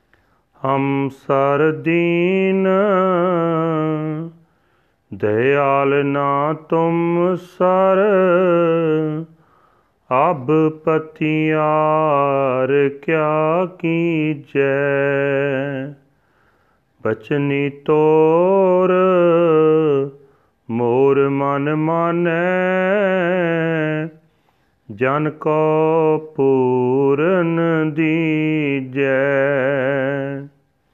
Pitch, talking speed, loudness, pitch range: 155 Hz, 35 wpm, -17 LUFS, 140-165 Hz